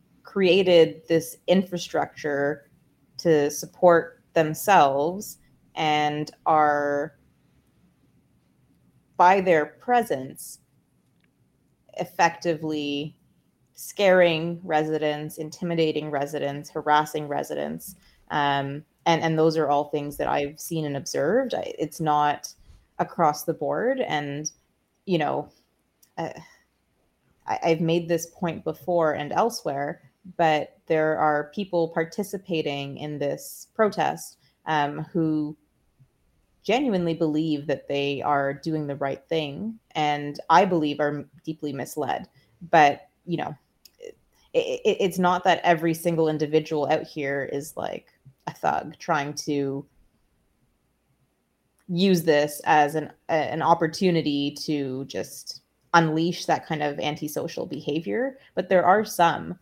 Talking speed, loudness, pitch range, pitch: 110 wpm, -24 LUFS, 145-170 Hz, 155 Hz